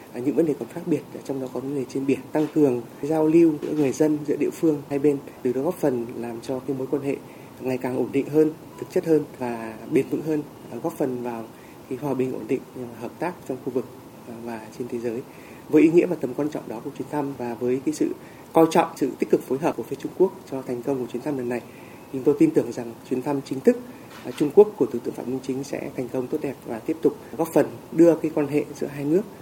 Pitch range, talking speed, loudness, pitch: 125-155 Hz, 270 wpm, -24 LUFS, 140 Hz